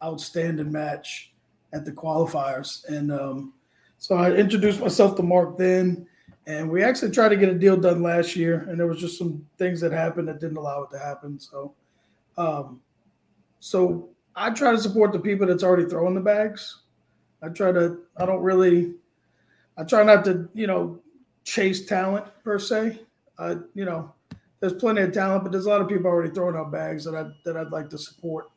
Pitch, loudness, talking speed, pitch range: 175 Hz, -23 LUFS, 195 wpm, 155-195 Hz